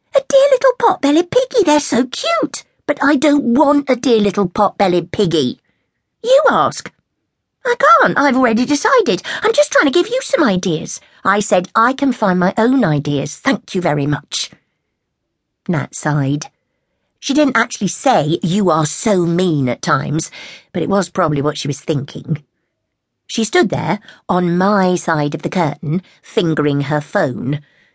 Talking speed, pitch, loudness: 160 wpm, 200 Hz, -15 LUFS